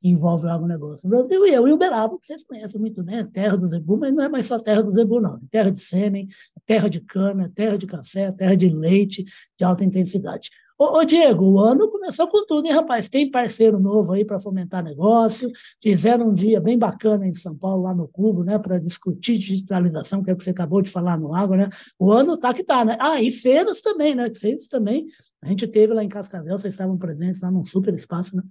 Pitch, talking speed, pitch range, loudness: 205 Hz, 235 wpm, 185-235 Hz, -20 LUFS